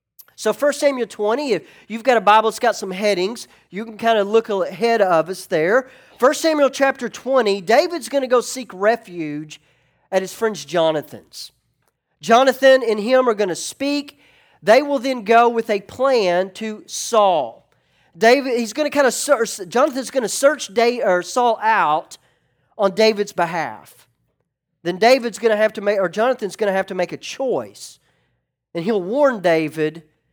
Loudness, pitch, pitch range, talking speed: -18 LUFS, 220 Hz, 190-255 Hz, 180 wpm